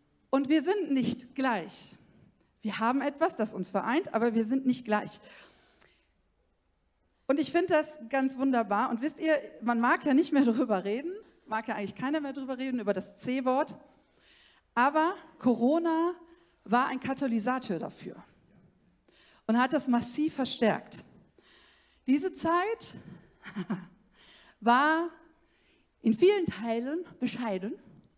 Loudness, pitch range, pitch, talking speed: -29 LUFS, 225-315 Hz, 260 Hz, 130 wpm